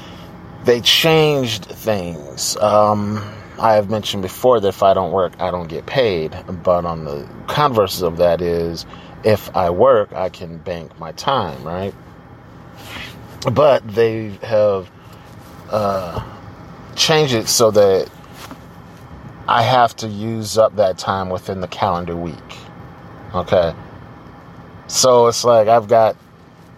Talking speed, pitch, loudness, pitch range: 130 wpm, 105 Hz, -16 LUFS, 90-115 Hz